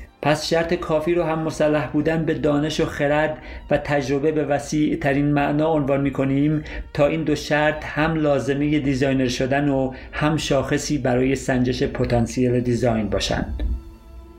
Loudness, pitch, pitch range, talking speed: -21 LUFS, 145 Hz, 130-150 Hz, 145 wpm